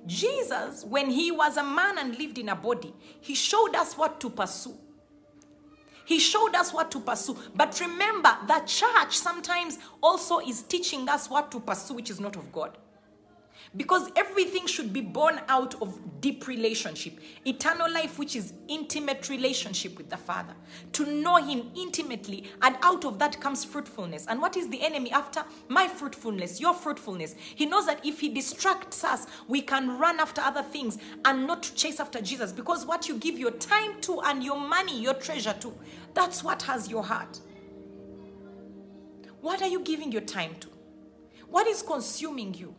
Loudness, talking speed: -27 LUFS, 175 wpm